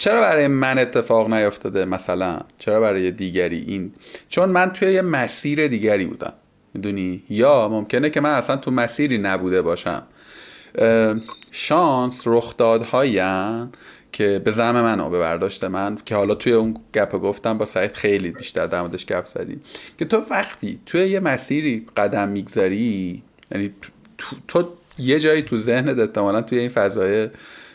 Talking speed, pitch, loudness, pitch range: 150 wpm, 115 Hz, -20 LUFS, 100-145 Hz